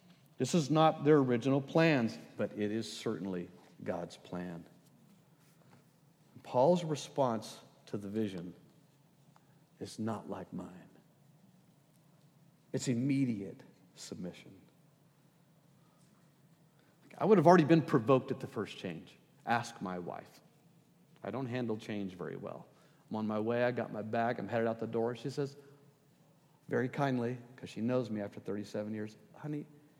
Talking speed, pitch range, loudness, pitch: 140 wpm, 115-155 Hz, -34 LUFS, 140 Hz